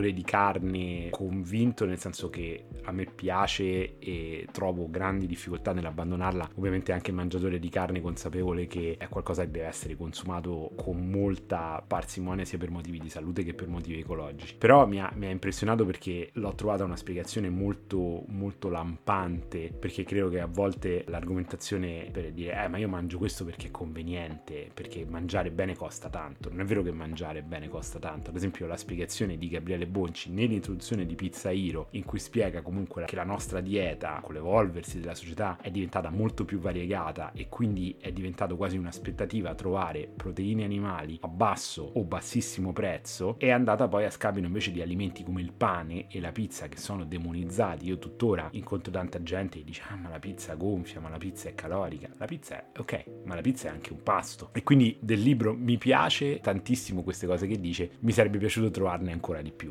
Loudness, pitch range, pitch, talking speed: -31 LUFS, 85-100 Hz, 95 Hz, 190 wpm